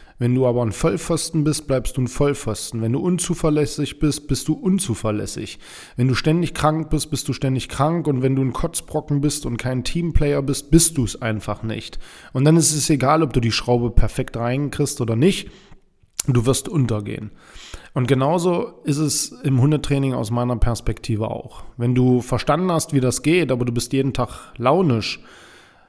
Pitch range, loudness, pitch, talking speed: 120-155 Hz, -20 LUFS, 135 Hz, 185 wpm